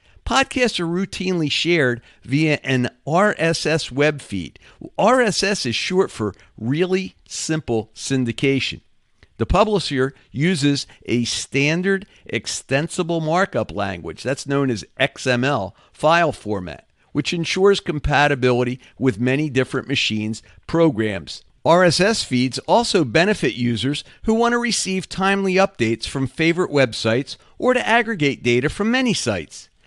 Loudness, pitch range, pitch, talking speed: -20 LUFS, 120-185 Hz, 145 Hz, 120 wpm